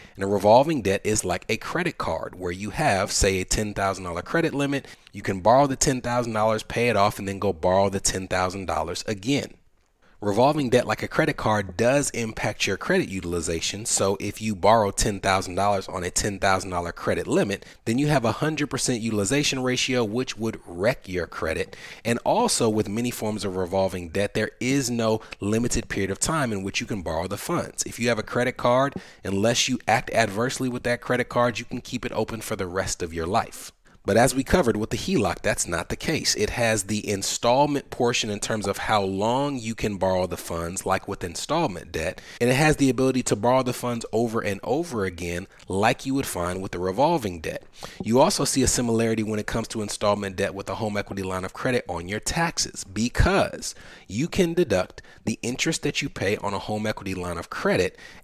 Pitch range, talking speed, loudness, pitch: 95-125 Hz, 205 wpm, -24 LUFS, 110 Hz